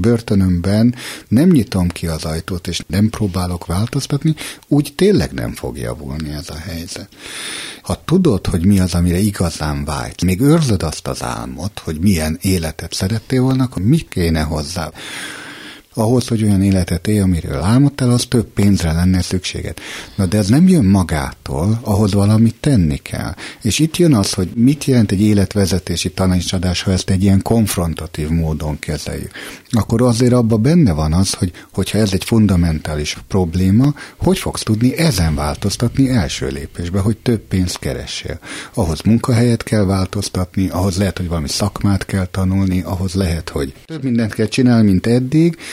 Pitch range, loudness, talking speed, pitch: 85-115 Hz, -16 LUFS, 160 wpm, 95 Hz